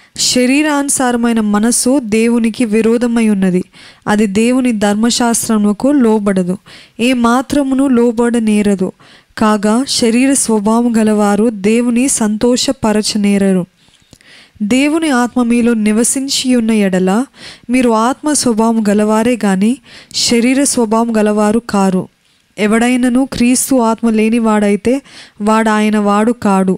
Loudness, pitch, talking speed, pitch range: -12 LUFS, 230 Hz, 95 wpm, 210-245 Hz